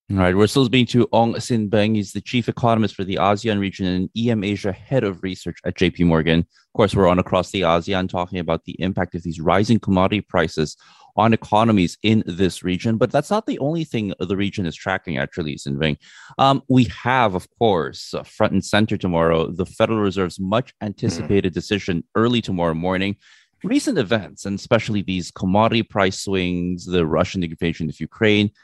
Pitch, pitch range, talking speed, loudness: 100 Hz, 90-110 Hz, 190 wpm, -20 LUFS